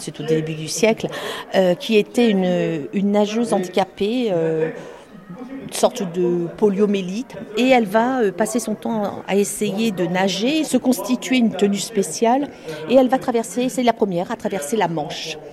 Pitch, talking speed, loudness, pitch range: 210 Hz, 170 wpm, -20 LUFS, 180-230 Hz